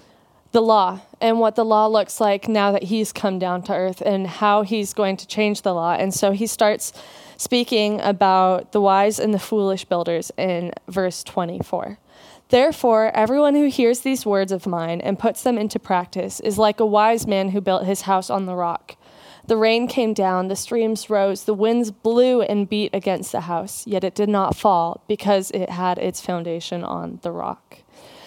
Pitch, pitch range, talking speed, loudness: 205 Hz, 190-220 Hz, 195 wpm, -20 LUFS